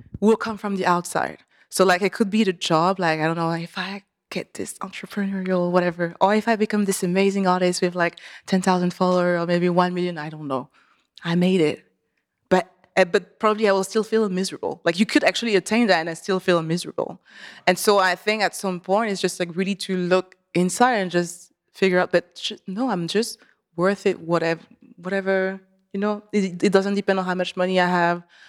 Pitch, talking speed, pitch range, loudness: 185 Hz, 215 wpm, 175-200 Hz, -22 LUFS